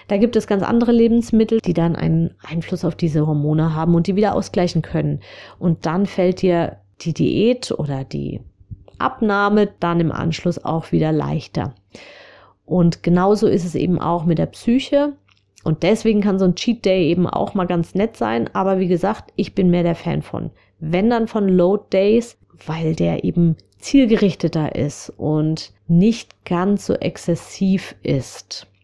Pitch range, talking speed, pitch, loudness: 160-205 Hz, 170 wpm, 175 Hz, -19 LUFS